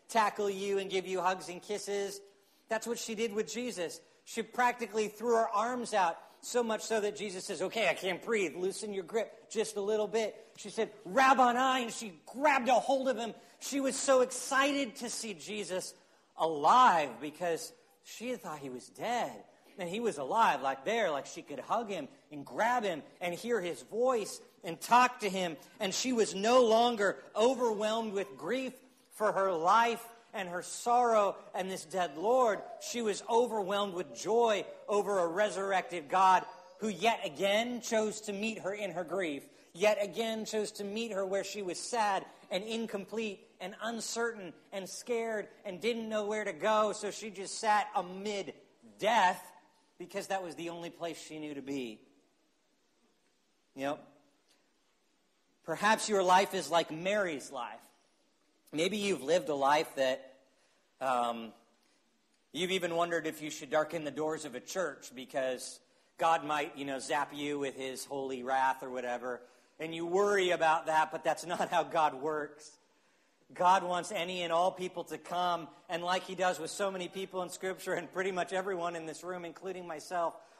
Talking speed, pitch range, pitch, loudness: 180 wpm, 170-220 Hz, 195 Hz, -33 LUFS